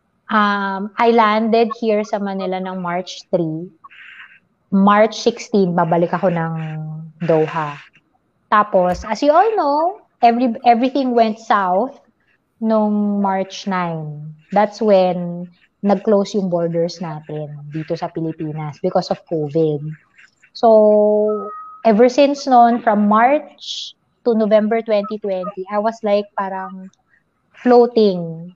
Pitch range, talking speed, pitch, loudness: 175-225 Hz, 110 wpm, 200 Hz, -17 LUFS